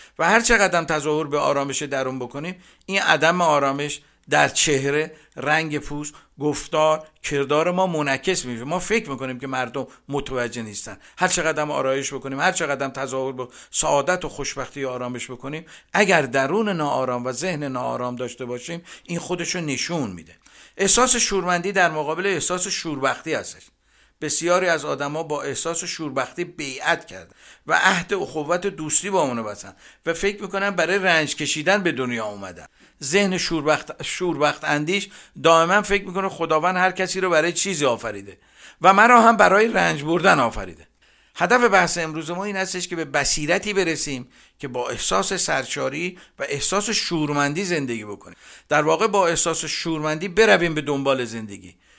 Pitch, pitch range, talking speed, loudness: 155 Hz, 135-180 Hz, 155 wpm, -21 LUFS